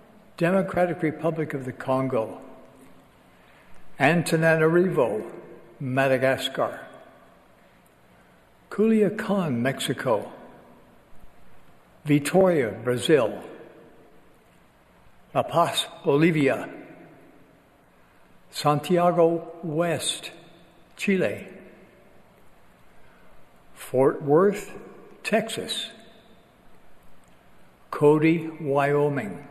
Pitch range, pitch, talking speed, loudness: 140-180 Hz, 165 Hz, 45 wpm, -24 LUFS